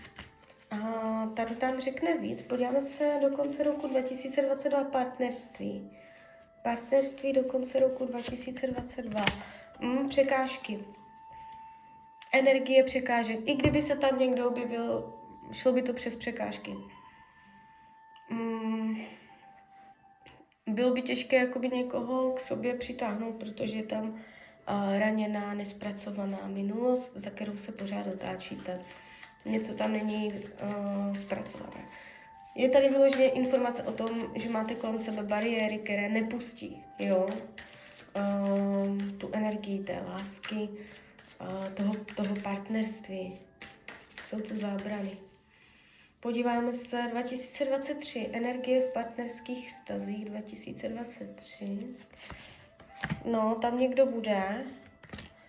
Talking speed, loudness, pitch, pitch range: 105 wpm, -32 LUFS, 230 Hz, 205-260 Hz